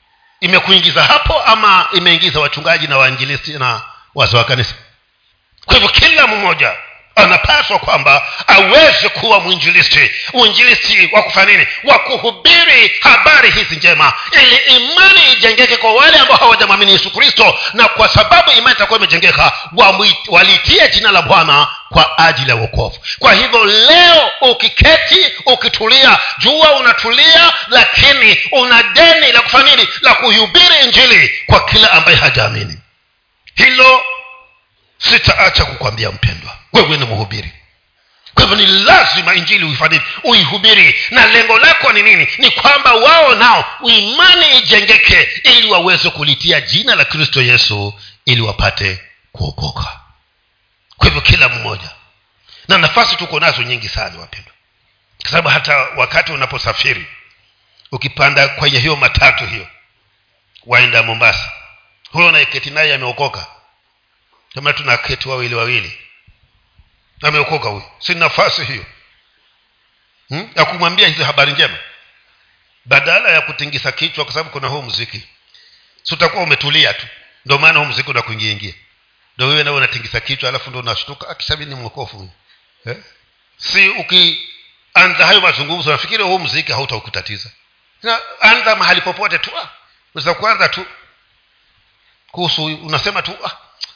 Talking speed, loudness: 105 wpm, -8 LUFS